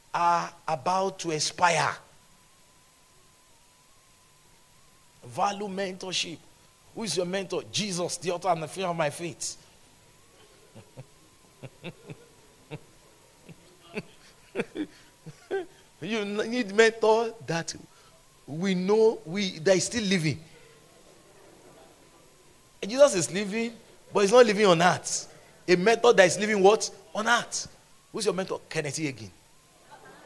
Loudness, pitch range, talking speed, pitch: -26 LUFS, 165-210 Hz, 105 wpm, 185 Hz